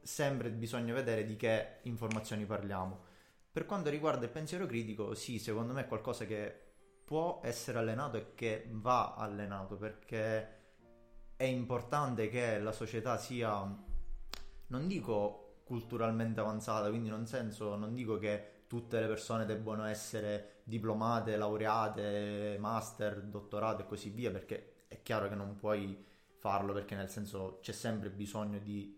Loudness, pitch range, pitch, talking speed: -39 LUFS, 105-115 Hz, 110 Hz, 145 wpm